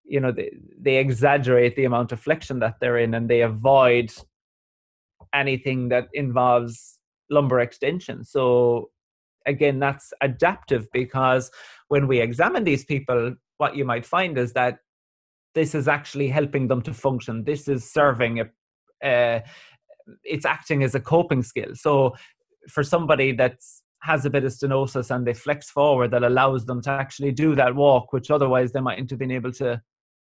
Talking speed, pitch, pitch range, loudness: 165 wpm, 130 Hz, 120-145 Hz, -22 LUFS